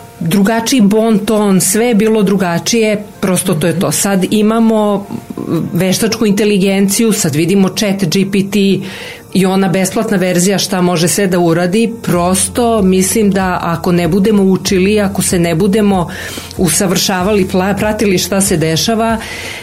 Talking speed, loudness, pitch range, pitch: 135 wpm, -12 LUFS, 185-215 Hz, 195 Hz